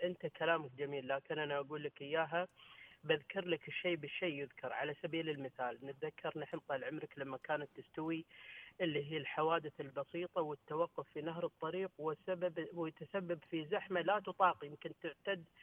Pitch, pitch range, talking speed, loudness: 160 Hz, 145-175 Hz, 150 wpm, -41 LUFS